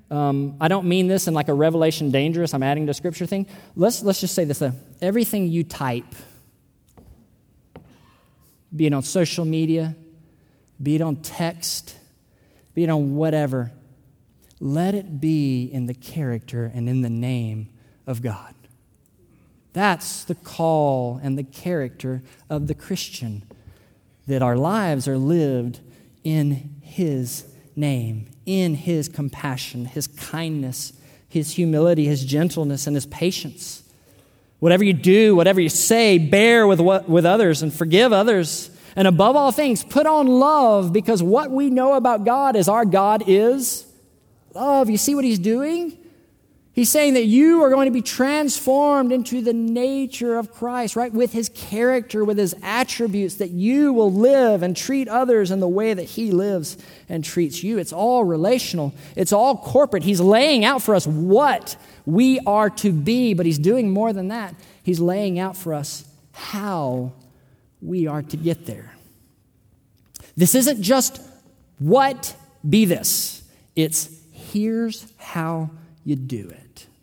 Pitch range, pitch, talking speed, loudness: 140-215 Hz, 170 Hz, 155 wpm, -20 LUFS